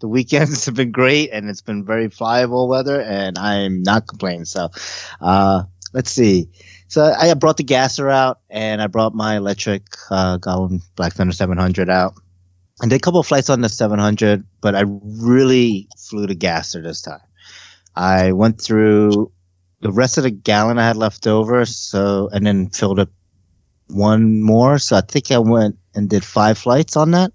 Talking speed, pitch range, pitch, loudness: 180 wpm, 95-125 Hz, 105 Hz, -16 LUFS